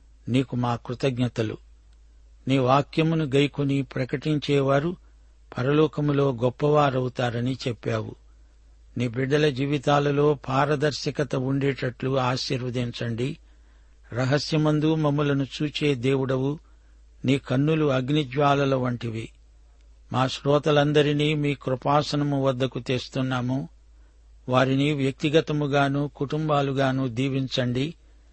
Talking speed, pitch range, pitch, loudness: 70 wpm, 120-145 Hz, 135 Hz, -24 LUFS